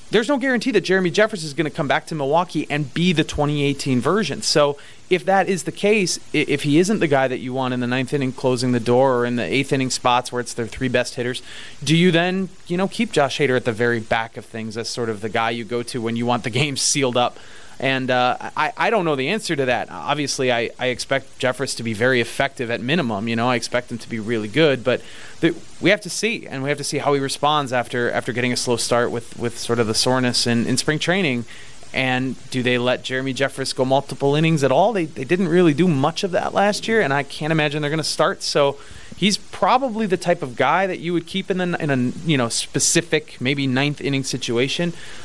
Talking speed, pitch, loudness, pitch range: 255 wpm, 135 Hz, -20 LUFS, 125-160 Hz